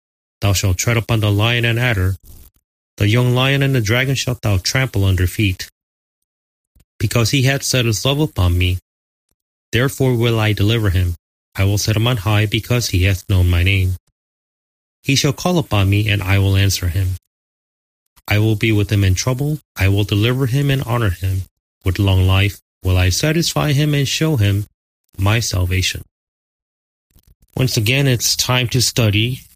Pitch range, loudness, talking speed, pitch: 90-125 Hz, -17 LUFS, 175 wpm, 105 Hz